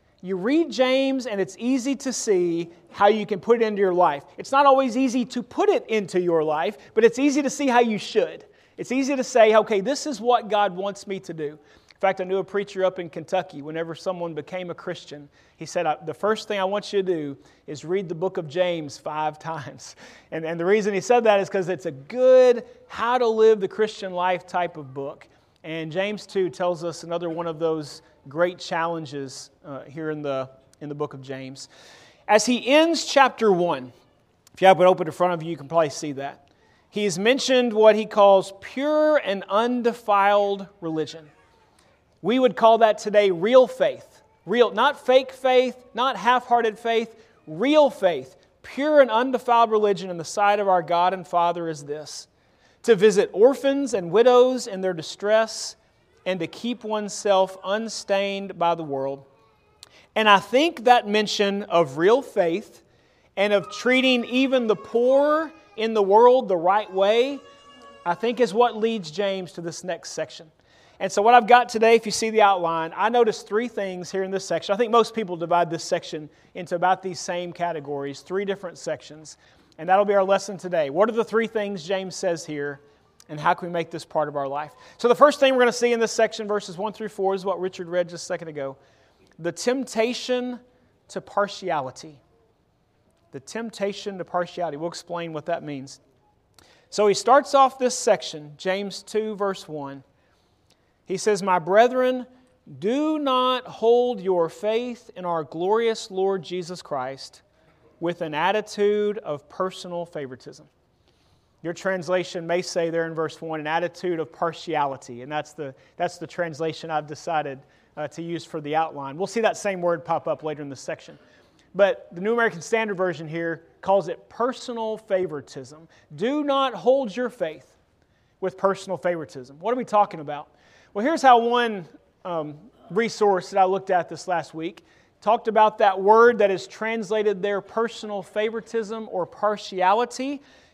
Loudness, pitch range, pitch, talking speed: -22 LUFS, 165-225 Hz, 195 Hz, 185 wpm